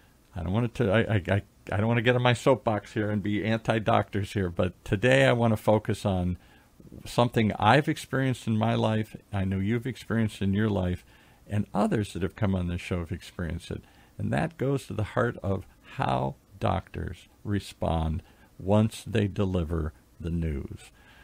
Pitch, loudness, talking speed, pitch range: 105 Hz, -28 LUFS, 185 wpm, 95-115 Hz